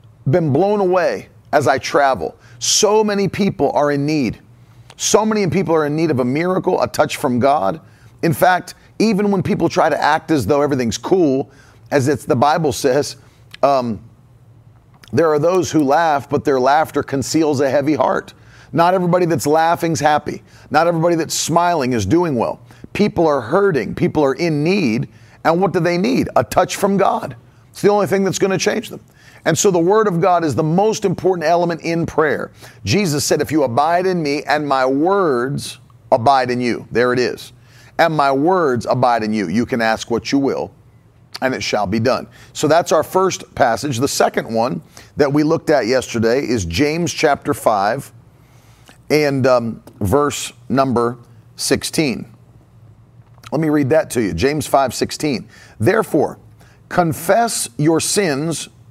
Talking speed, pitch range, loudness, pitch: 175 wpm, 120-175 Hz, -17 LUFS, 145 Hz